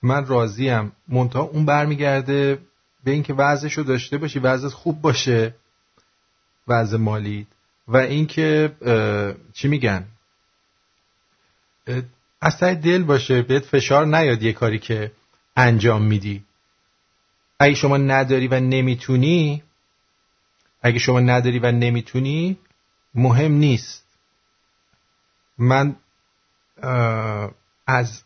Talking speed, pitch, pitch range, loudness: 100 wpm, 130 Hz, 115-145 Hz, -19 LUFS